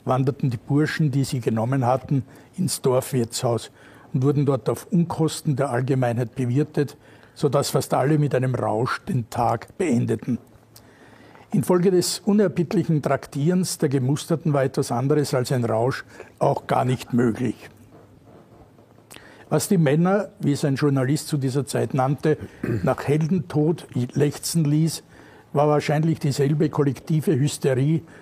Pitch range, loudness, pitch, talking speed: 125-155 Hz, -23 LUFS, 140 Hz, 135 wpm